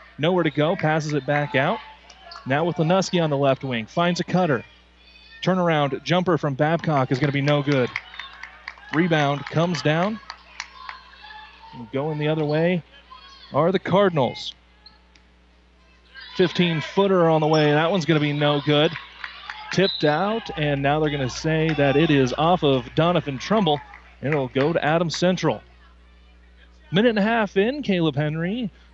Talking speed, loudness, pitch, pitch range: 160 wpm, -22 LUFS, 155 Hz, 140-180 Hz